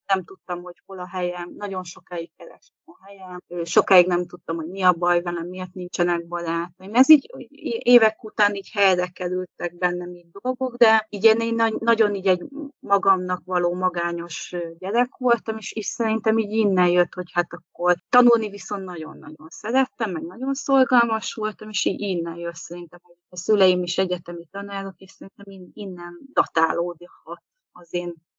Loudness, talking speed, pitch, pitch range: -22 LUFS, 165 wpm, 185 Hz, 175-220 Hz